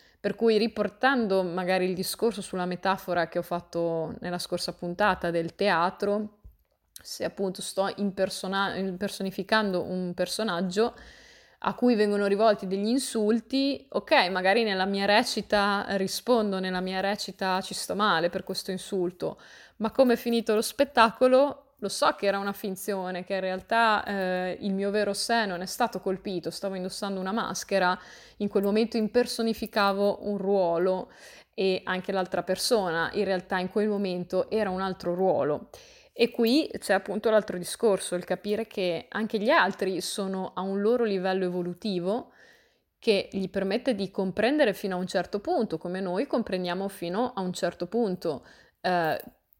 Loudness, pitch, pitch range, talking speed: -27 LUFS, 195 Hz, 185-220 Hz, 155 wpm